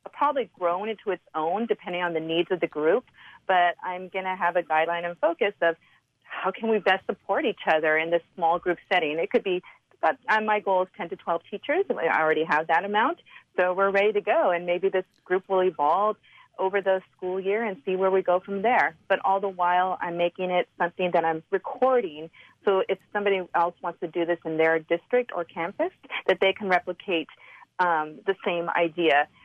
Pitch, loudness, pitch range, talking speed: 185 Hz, -25 LUFS, 170-200 Hz, 215 wpm